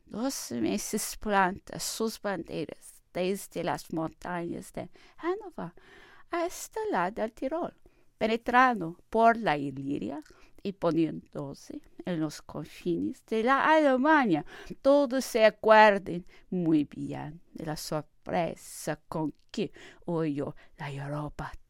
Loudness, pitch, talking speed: -29 LUFS, 205 Hz, 110 wpm